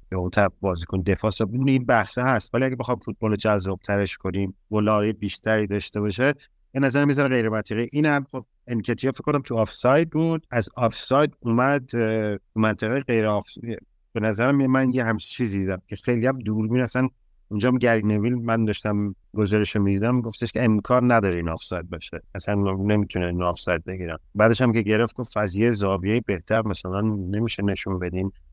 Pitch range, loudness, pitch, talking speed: 100-125 Hz, -23 LUFS, 110 Hz, 180 wpm